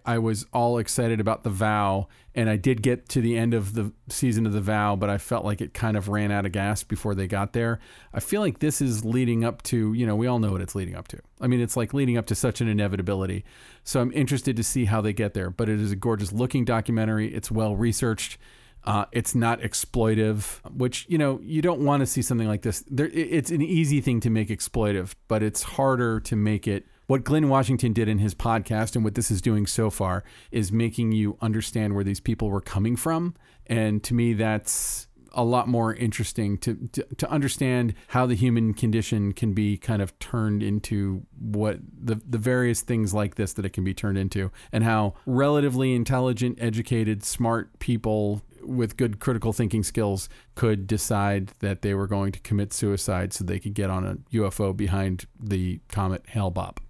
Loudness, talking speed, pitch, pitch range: -25 LUFS, 215 wpm, 110 Hz, 105-120 Hz